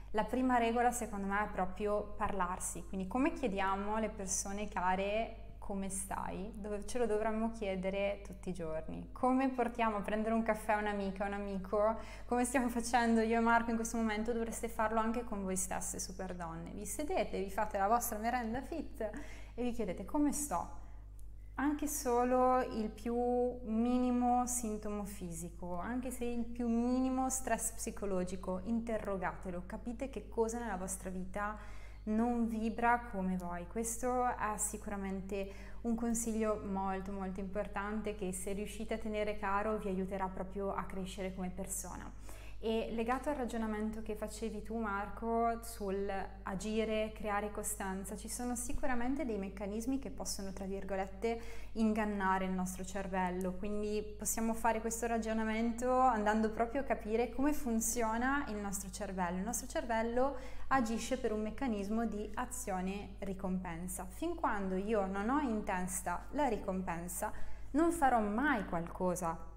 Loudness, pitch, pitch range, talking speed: -37 LUFS, 215 Hz, 195-235 Hz, 150 wpm